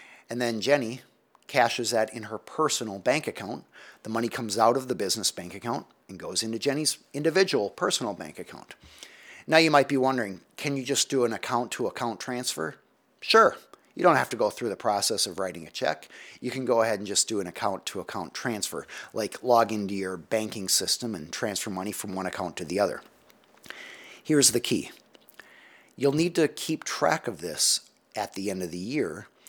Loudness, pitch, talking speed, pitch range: -27 LUFS, 120 Hz, 195 wpm, 105-140 Hz